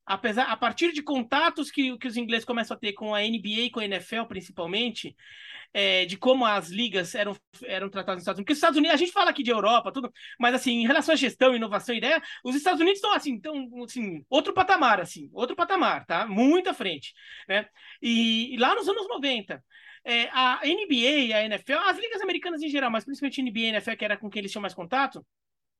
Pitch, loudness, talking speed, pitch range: 245 Hz, -25 LUFS, 230 wpm, 215-295 Hz